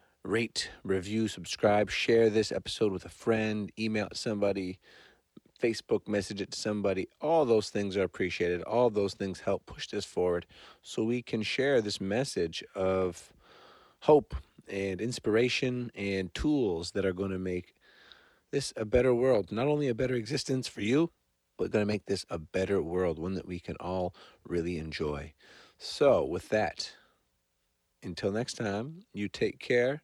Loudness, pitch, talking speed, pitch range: -31 LUFS, 100 Hz, 160 wpm, 90-115 Hz